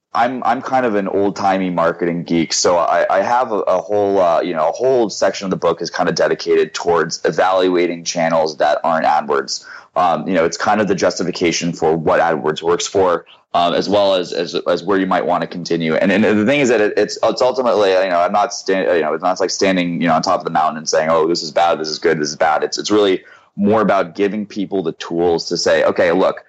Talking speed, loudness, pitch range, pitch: 255 wpm, -16 LUFS, 85-100 Hz, 90 Hz